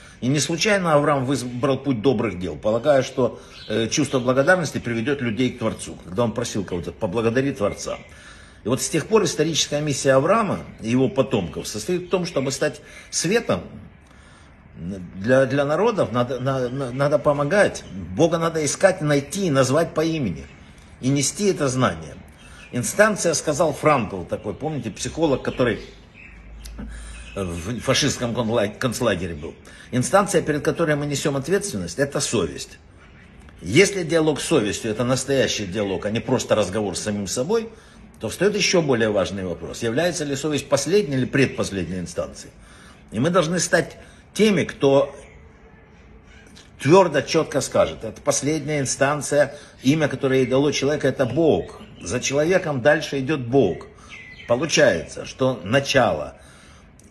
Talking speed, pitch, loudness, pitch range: 140 wpm, 135 Hz, -21 LUFS, 115-150 Hz